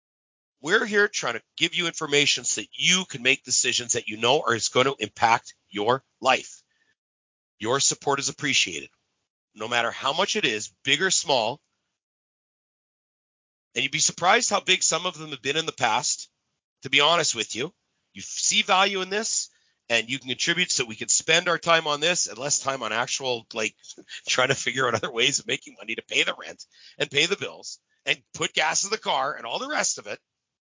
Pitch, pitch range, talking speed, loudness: 145 Hz, 120-180 Hz, 210 wpm, -23 LUFS